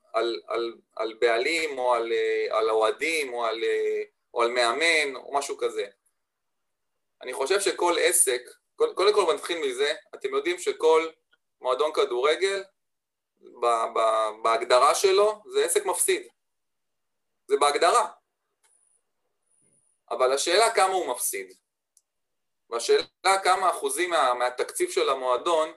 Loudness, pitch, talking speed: -24 LUFS, 395 Hz, 115 wpm